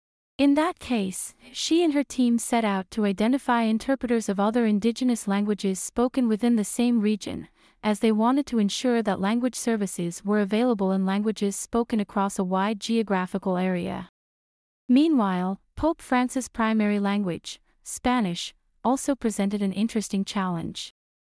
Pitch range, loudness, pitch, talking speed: 195-245 Hz, -25 LUFS, 220 Hz, 140 wpm